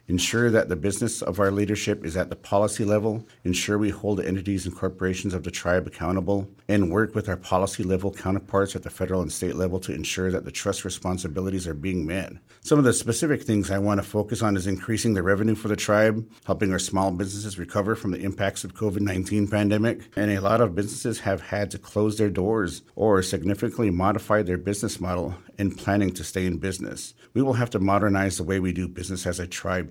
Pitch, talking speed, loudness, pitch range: 100 Hz, 220 wpm, -25 LUFS, 95-105 Hz